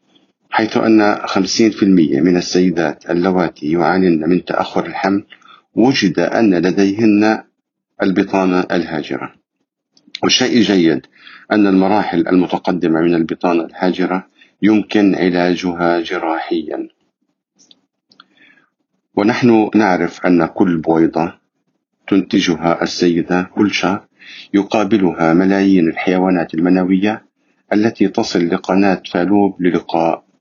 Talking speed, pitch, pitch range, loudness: 85 wpm, 90 Hz, 85-105 Hz, -15 LUFS